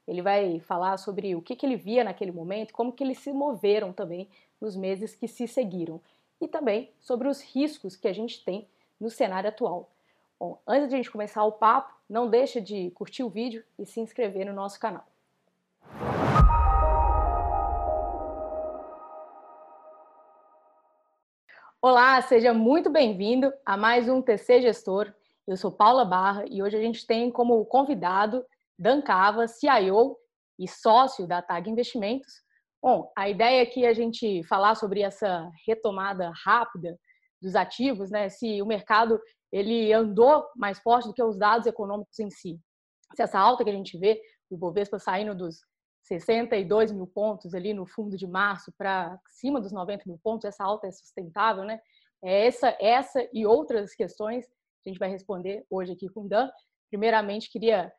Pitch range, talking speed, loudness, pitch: 190-235 Hz, 160 wpm, -26 LUFS, 210 Hz